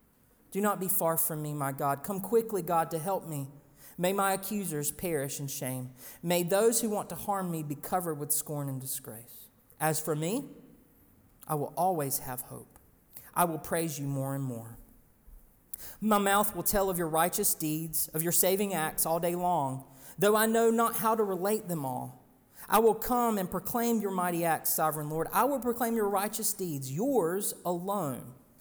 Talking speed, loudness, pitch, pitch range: 190 wpm, -30 LUFS, 170 Hz, 145-200 Hz